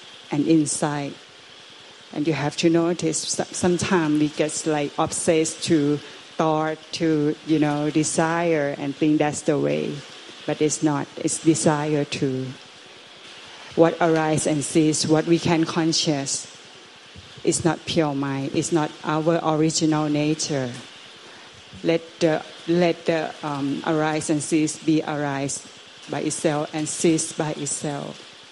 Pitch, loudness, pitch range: 155 Hz, -22 LUFS, 150-165 Hz